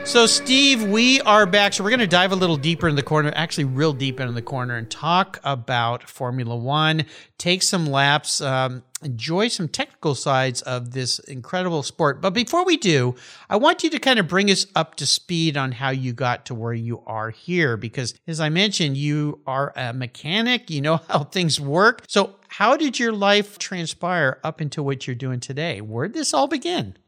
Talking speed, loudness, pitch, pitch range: 205 wpm, -20 LUFS, 155 Hz, 130-195 Hz